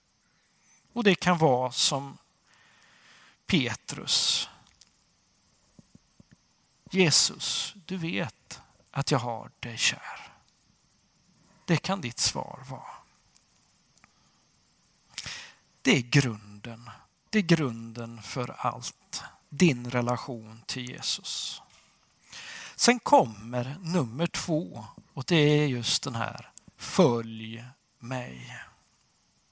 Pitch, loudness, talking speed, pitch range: 140 Hz, -27 LUFS, 85 wpm, 120-175 Hz